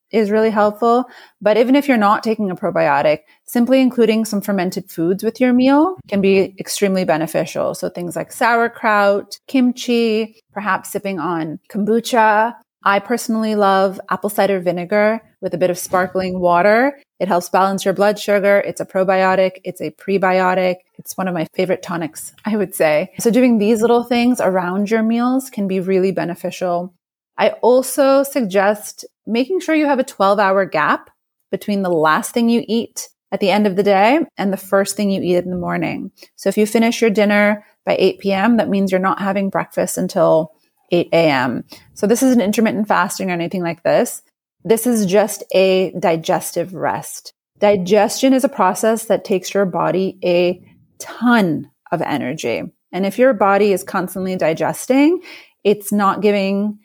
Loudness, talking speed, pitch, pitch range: -17 LUFS, 175 wpm, 200 Hz, 185-225 Hz